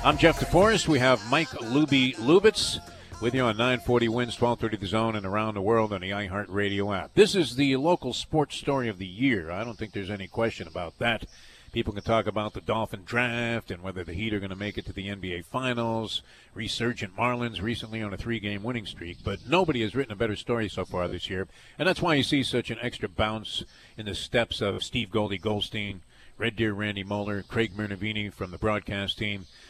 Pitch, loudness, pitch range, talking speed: 110 Hz, -27 LUFS, 100-120 Hz, 215 wpm